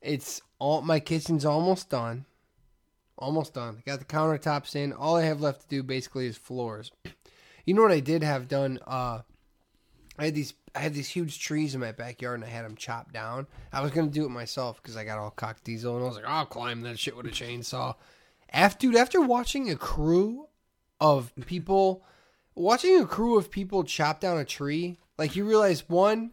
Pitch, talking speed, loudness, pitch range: 145 Hz, 205 wpm, -28 LUFS, 125-170 Hz